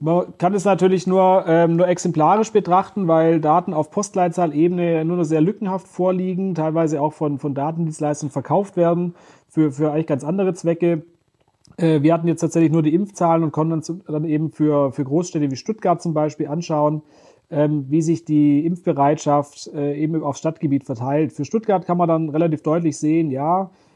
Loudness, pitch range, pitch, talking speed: -19 LUFS, 150-175 Hz, 160 Hz, 180 wpm